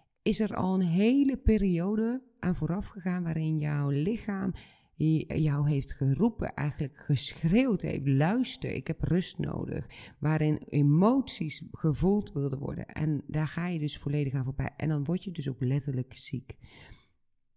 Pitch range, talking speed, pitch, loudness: 145-190 Hz, 150 wpm, 155 Hz, -30 LUFS